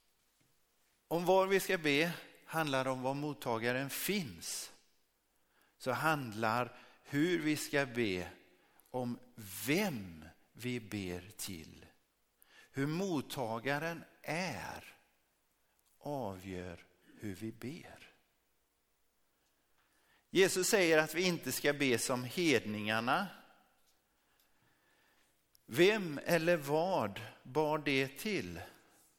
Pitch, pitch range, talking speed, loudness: 130 Hz, 110-155 Hz, 90 wpm, -35 LUFS